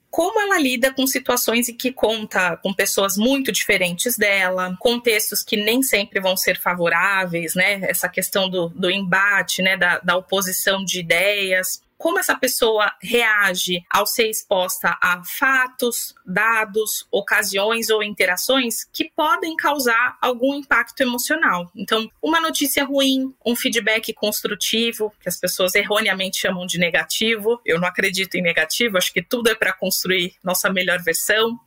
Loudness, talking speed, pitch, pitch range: -19 LUFS, 150 wpm, 210 Hz, 185-240 Hz